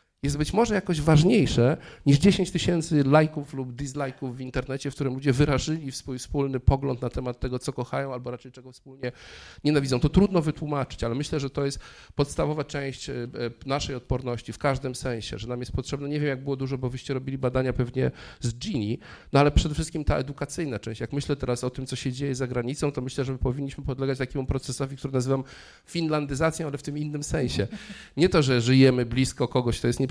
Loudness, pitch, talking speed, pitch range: -26 LUFS, 135 Hz, 205 wpm, 125-145 Hz